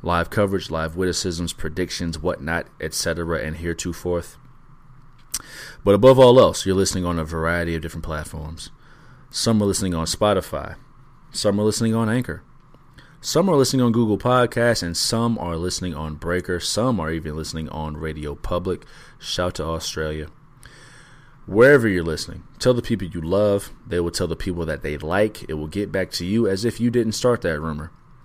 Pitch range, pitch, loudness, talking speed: 80-115 Hz, 90 Hz, -21 LUFS, 175 wpm